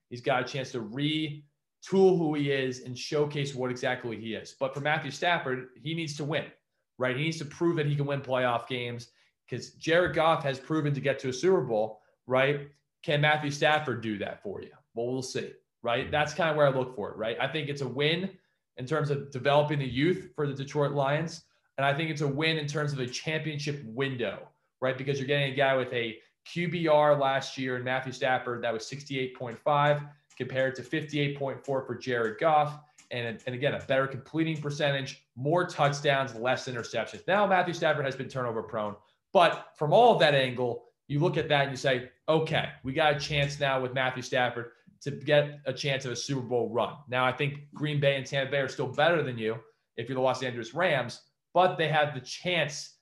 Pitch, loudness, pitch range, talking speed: 140 Hz, -29 LUFS, 130-150 Hz, 215 wpm